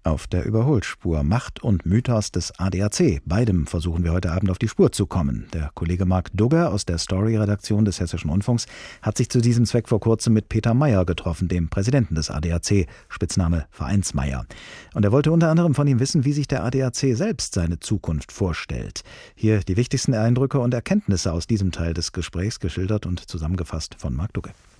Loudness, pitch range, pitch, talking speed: -22 LUFS, 90-120 Hz, 100 Hz, 190 wpm